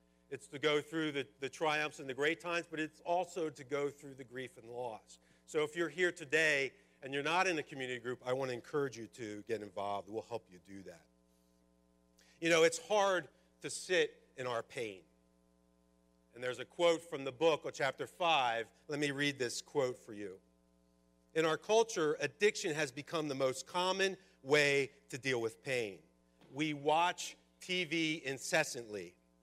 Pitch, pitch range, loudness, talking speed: 140 Hz, 100-160 Hz, -36 LUFS, 185 wpm